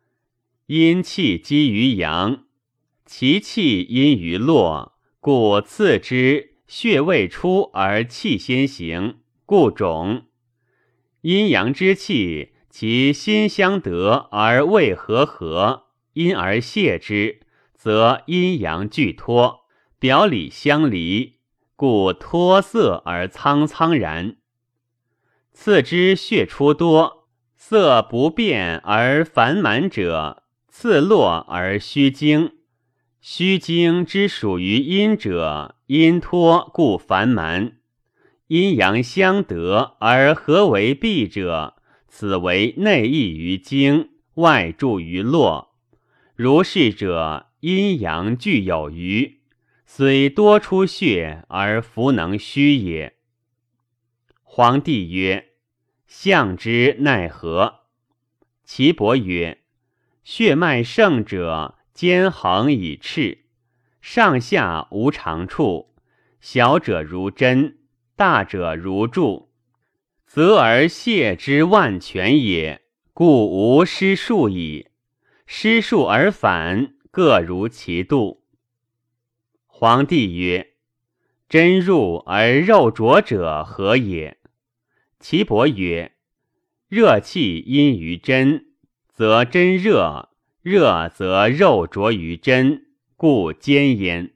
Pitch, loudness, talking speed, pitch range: 125 Hz, -17 LUFS, 130 characters per minute, 105-160 Hz